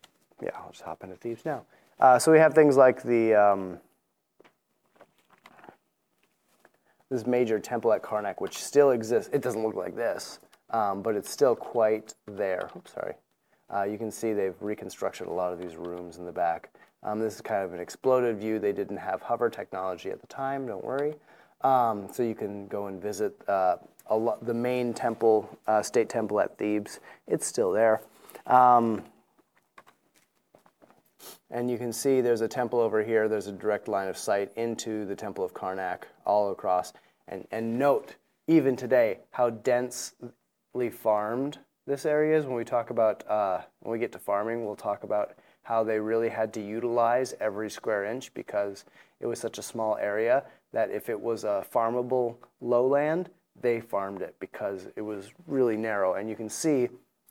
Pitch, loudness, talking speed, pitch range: 115 Hz, -28 LUFS, 180 wpm, 105-125 Hz